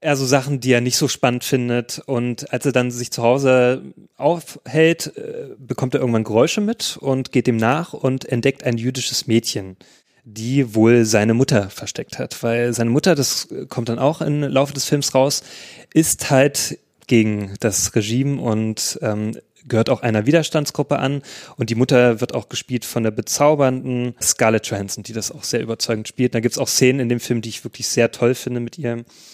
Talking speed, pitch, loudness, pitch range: 195 wpm, 125 Hz, -19 LUFS, 115-140 Hz